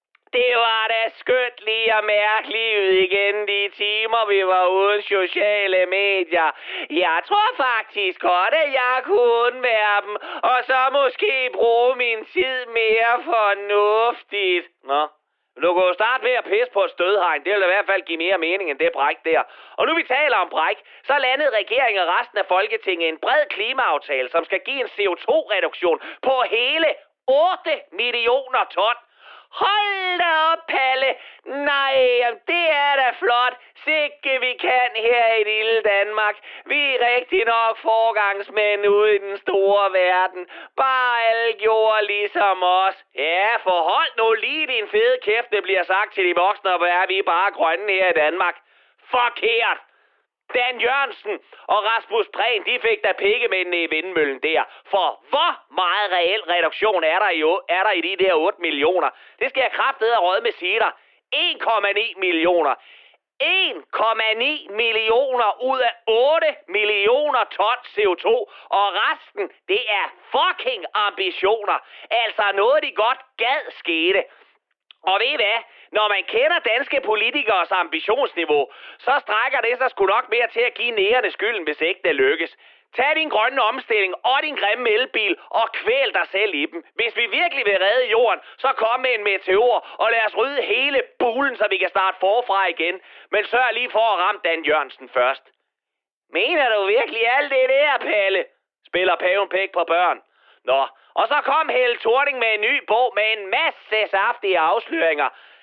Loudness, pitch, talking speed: -19 LUFS, 245 Hz, 165 wpm